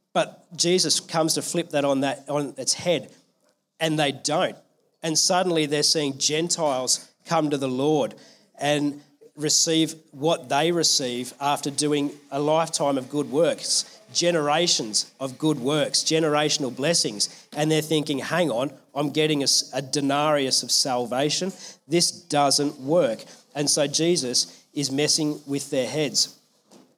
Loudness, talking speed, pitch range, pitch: -23 LUFS, 140 wpm, 140-160 Hz, 150 Hz